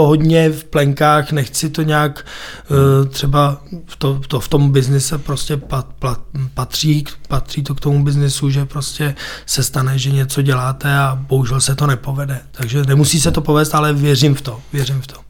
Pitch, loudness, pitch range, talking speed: 140 Hz, -16 LUFS, 135-150 Hz, 175 wpm